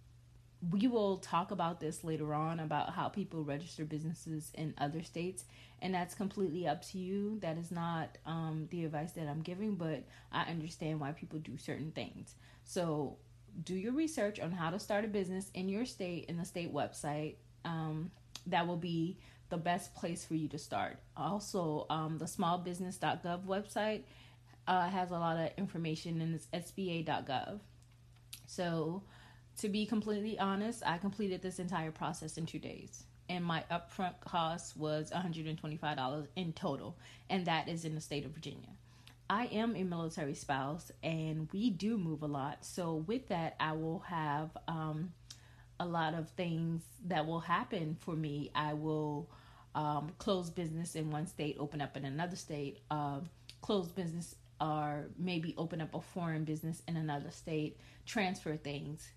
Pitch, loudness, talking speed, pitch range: 160 Hz, -39 LUFS, 165 wpm, 150-180 Hz